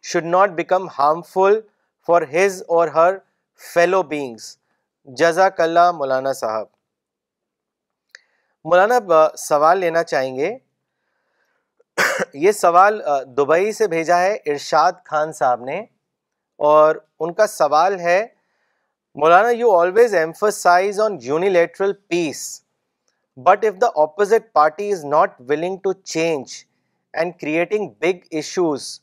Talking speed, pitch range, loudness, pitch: 115 wpm, 155-200 Hz, -18 LUFS, 175 Hz